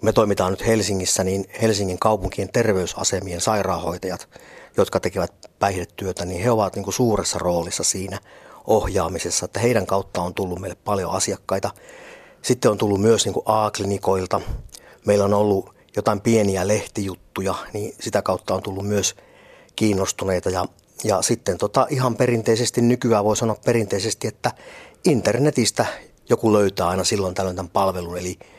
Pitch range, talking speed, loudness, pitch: 95-110 Hz, 145 wpm, -21 LUFS, 100 Hz